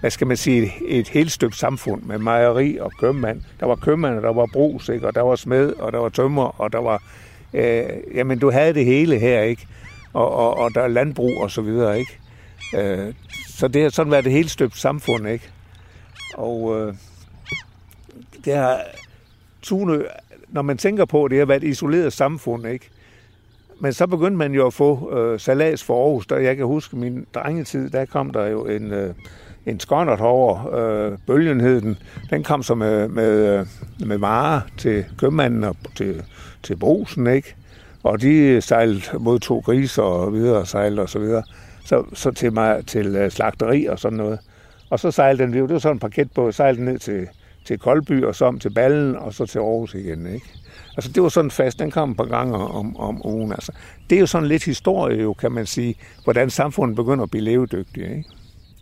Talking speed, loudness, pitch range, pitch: 205 wpm, -20 LUFS, 105-135 Hz, 120 Hz